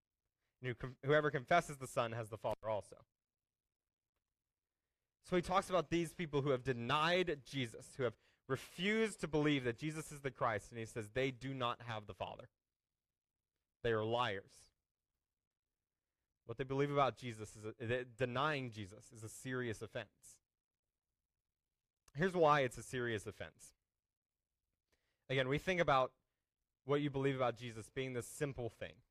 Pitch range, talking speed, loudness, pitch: 115-145 Hz, 155 wpm, -39 LUFS, 130 Hz